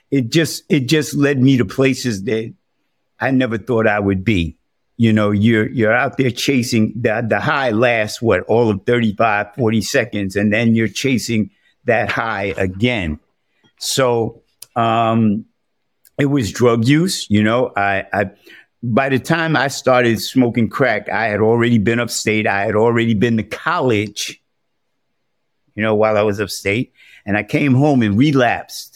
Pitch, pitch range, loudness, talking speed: 115 Hz, 105-130 Hz, -16 LUFS, 165 wpm